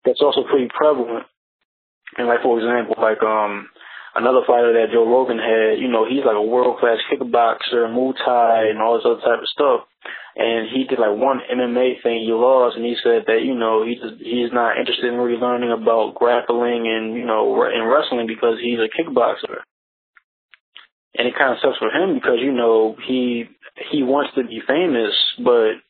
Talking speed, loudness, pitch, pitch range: 195 wpm, -18 LUFS, 120 Hz, 115-125 Hz